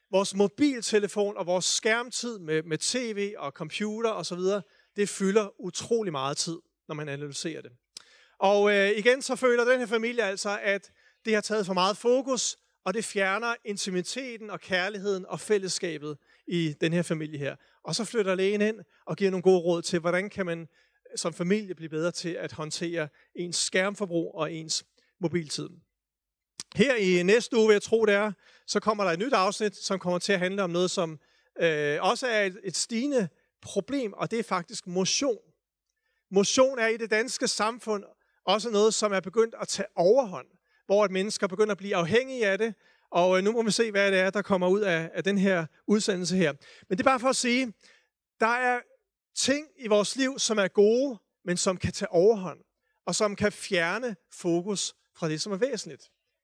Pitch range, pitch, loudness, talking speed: 180-225 Hz, 200 Hz, -27 LUFS, 190 wpm